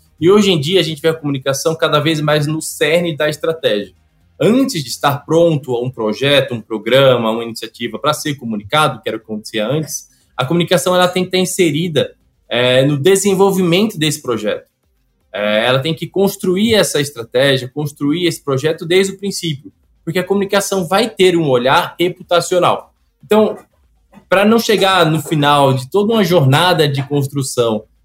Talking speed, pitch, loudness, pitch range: 170 wpm, 155 Hz, -15 LUFS, 125-180 Hz